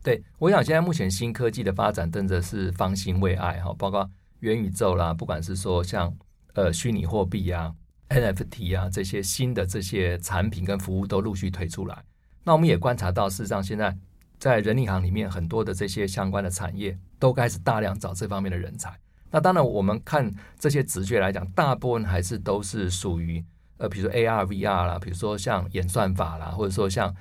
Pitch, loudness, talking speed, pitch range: 100 Hz, -26 LUFS, 310 characters per minute, 90-110 Hz